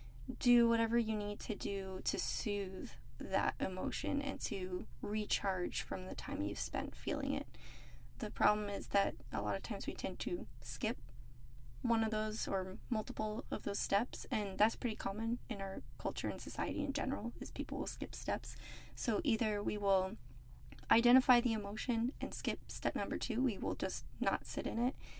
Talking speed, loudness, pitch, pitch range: 180 wpm, -37 LUFS, 220 Hz, 205-240 Hz